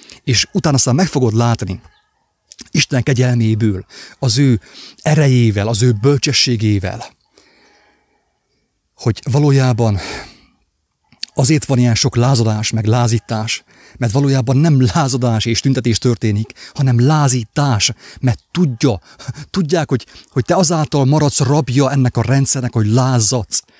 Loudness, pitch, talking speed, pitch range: -15 LUFS, 125 Hz, 115 wpm, 115-140 Hz